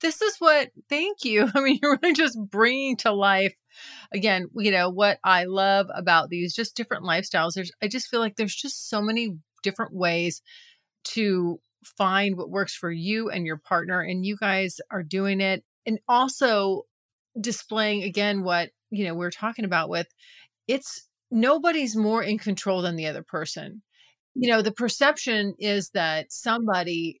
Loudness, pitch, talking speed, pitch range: -24 LUFS, 205 Hz, 170 wpm, 185-235 Hz